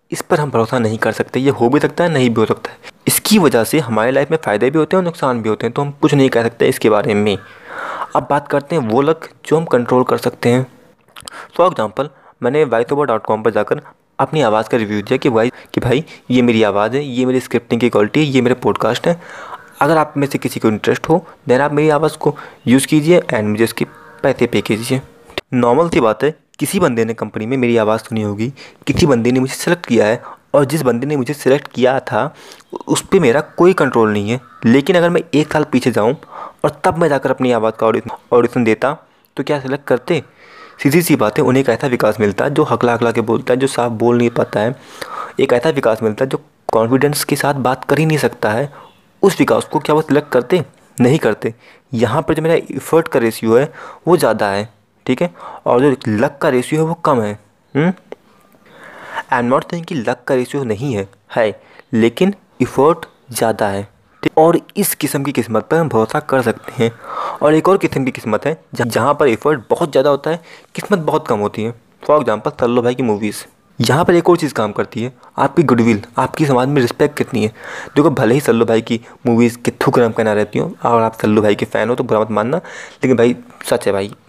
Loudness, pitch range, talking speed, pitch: -15 LUFS, 115-150 Hz, 225 wpm, 130 Hz